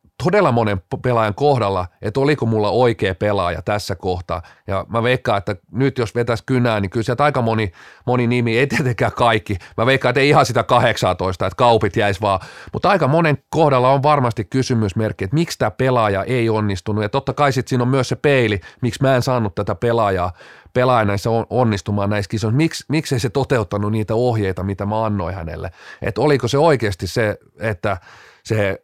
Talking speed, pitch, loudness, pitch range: 190 wpm, 115 Hz, -18 LUFS, 100-130 Hz